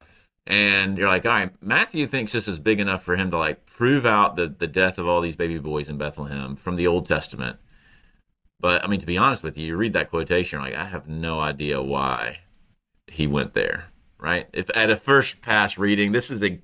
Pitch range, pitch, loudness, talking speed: 80-105 Hz, 90 Hz, -22 LUFS, 230 wpm